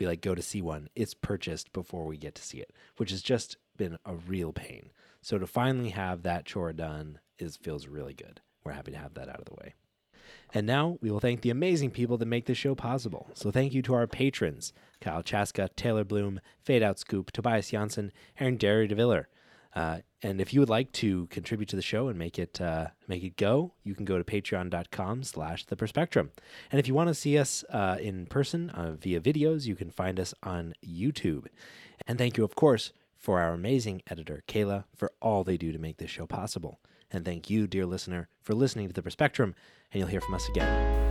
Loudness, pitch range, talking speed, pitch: -31 LUFS, 90-120 Hz, 220 wpm, 100 Hz